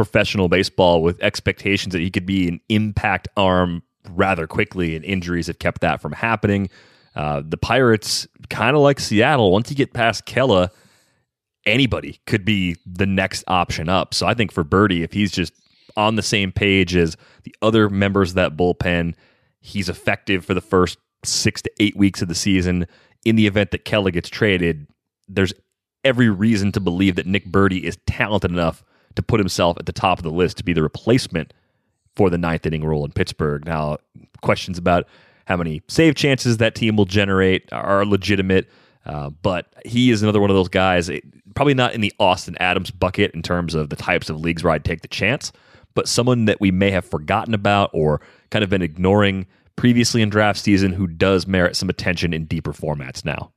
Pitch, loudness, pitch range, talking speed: 95 Hz, -19 LUFS, 90-105 Hz, 195 wpm